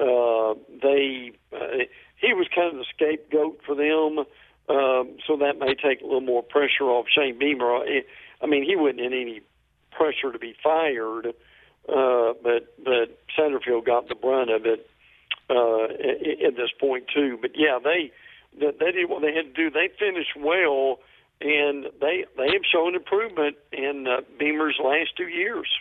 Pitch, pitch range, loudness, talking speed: 145 Hz, 125-210 Hz, -24 LUFS, 165 wpm